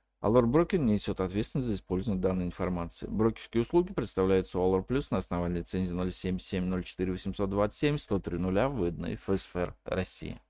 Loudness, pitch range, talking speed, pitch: -31 LUFS, 90-110 Hz, 120 wpm, 95 Hz